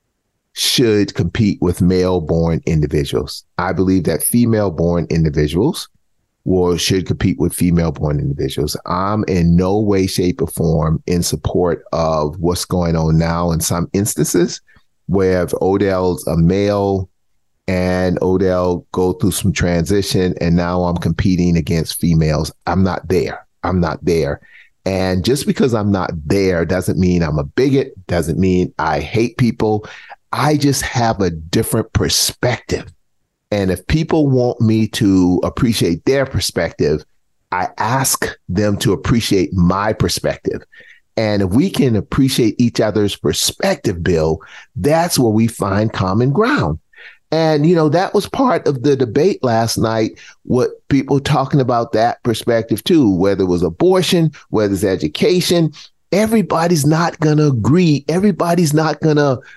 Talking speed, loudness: 145 wpm, -16 LUFS